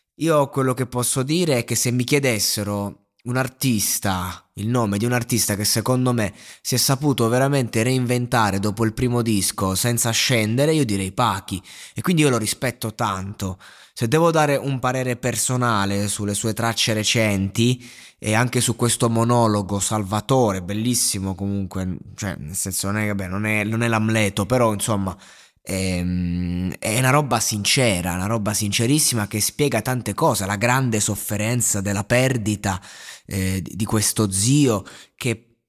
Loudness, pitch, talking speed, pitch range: -21 LUFS, 110 Hz, 155 wpm, 100-125 Hz